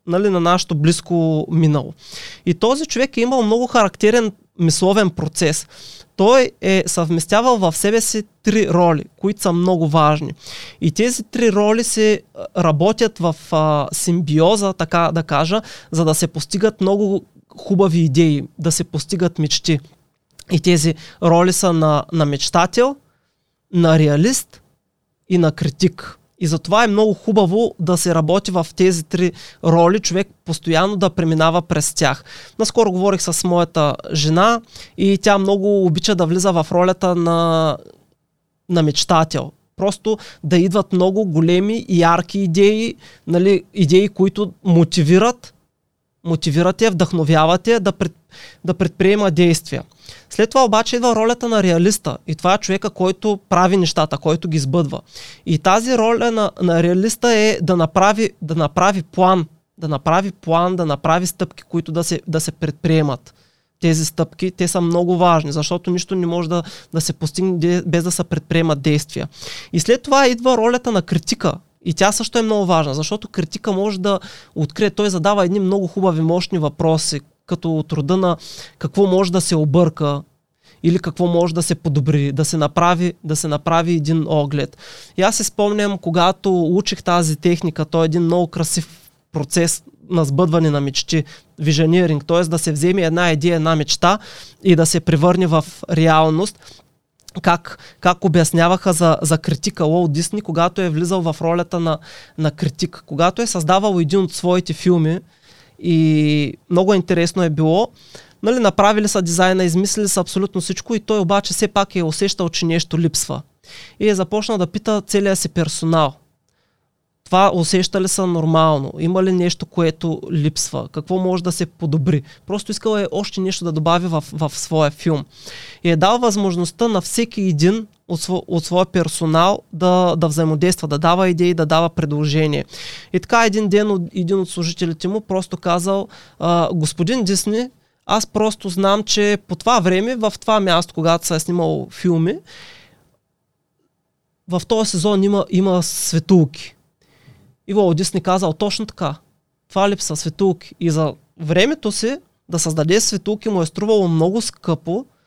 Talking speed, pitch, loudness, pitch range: 155 wpm, 175 Hz, -17 LUFS, 160-195 Hz